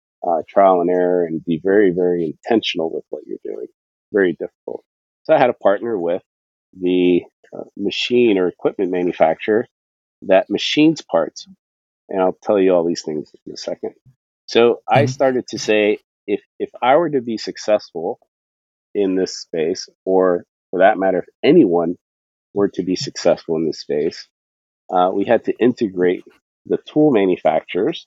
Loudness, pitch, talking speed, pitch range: -18 LUFS, 95 Hz, 160 wpm, 85-120 Hz